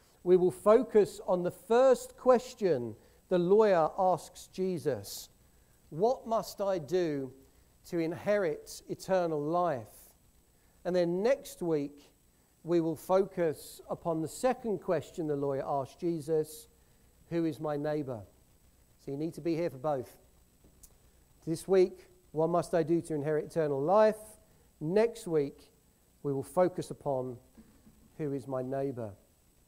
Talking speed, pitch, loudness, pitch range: 135 wpm, 165 Hz, -31 LUFS, 140-185 Hz